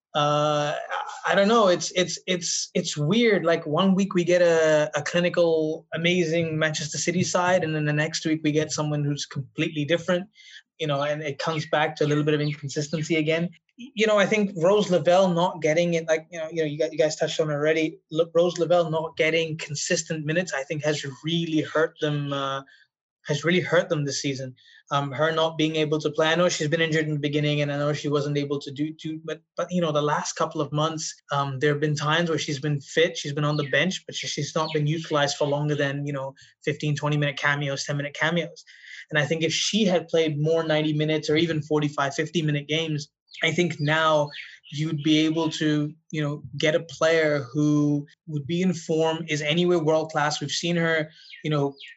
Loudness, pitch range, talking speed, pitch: -24 LUFS, 150-165 Hz, 220 wpm, 155 Hz